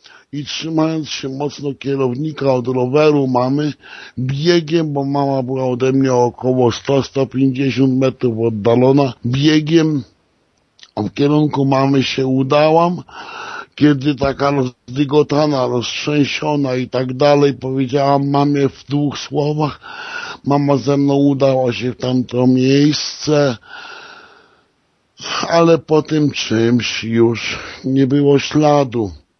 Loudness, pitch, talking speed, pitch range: -16 LUFS, 140 Hz, 110 wpm, 130-150 Hz